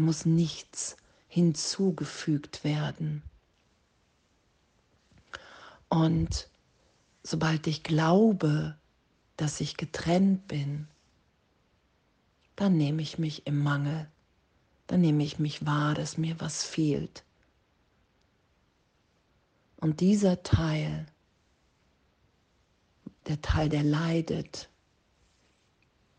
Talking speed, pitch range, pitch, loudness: 80 wpm, 145-165 Hz, 155 Hz, -29 LUFS